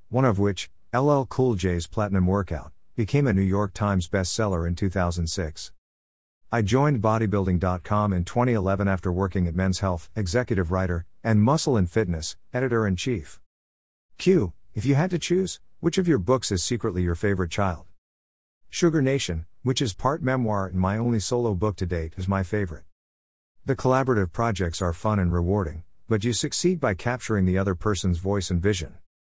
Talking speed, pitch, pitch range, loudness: 170 wpm, 100 Hz, 90-120 Hz, -25 LUFS